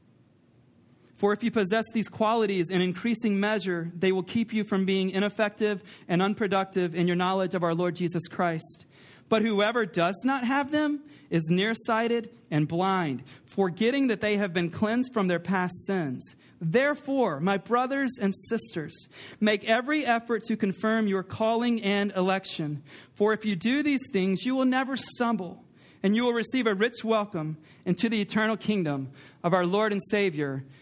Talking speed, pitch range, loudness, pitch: 165 wpm, 180-225 Hz, -27 LUFS, 205 Hz